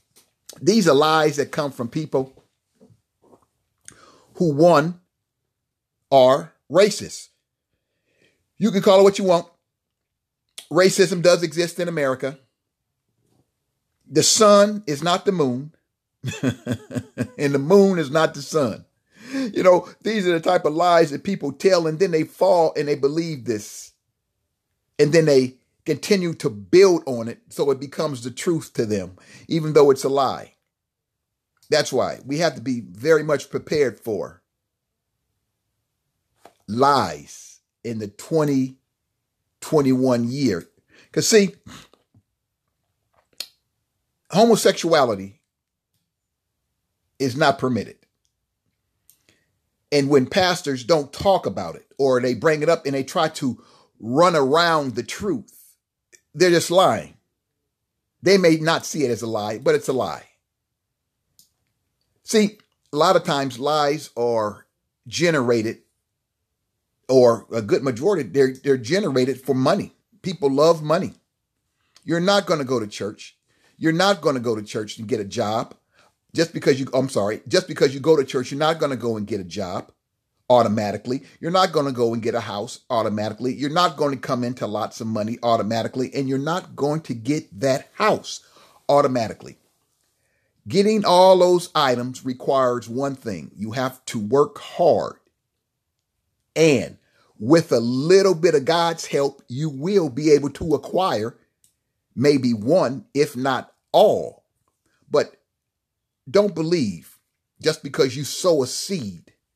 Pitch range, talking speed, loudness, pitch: 125-170 Hz, 140 wpm, -20 LUFS, 145 Hz